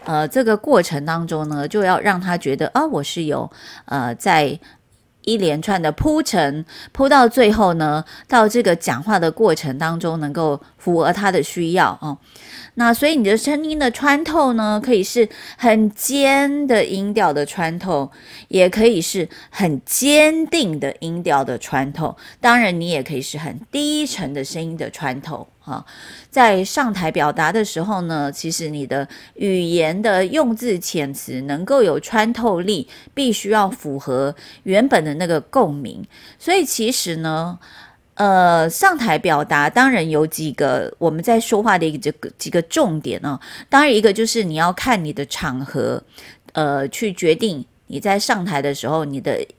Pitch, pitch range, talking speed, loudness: 180 Hz, 155-230 Hz, 235 characters per minute, -18 LUFS